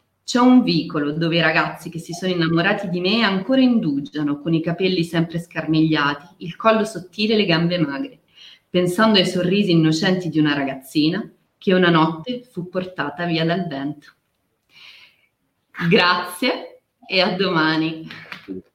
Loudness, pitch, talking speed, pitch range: -19 LUFS, 175 Hz, 145 wpm, 160-190 Hz